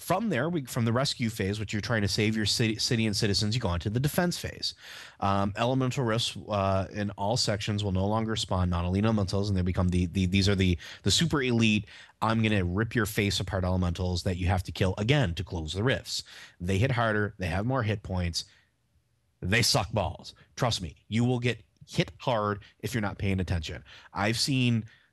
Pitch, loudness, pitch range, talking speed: 105 Hz, -28 LUFS, 95-115 Hz, 205 wpm